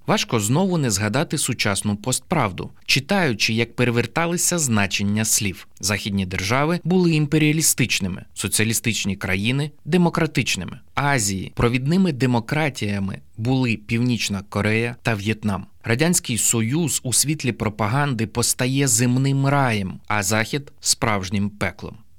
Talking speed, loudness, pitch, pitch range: 105 wpm, -21 LUFS, 120 Hz, 105-145 Hz